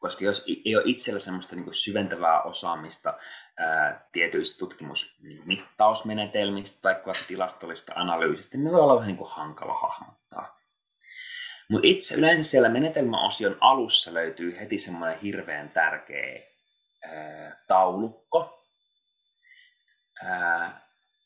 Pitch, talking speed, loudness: 305 Hz, 90 wpm, -24 LUFS